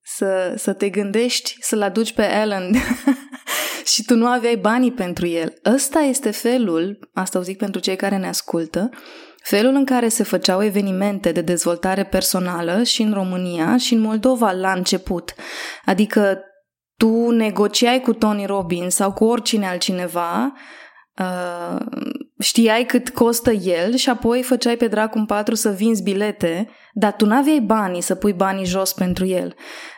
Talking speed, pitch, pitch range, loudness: 155 wpm, 215 Hz, 190-245 Hz, -19 LUFS